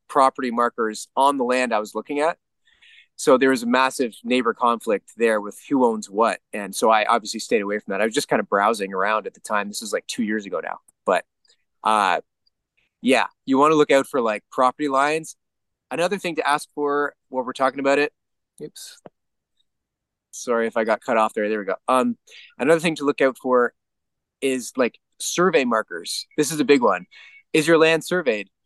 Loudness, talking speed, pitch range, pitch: -21 LUFS, 205 wpm, 110-150 Hz, 130 Hz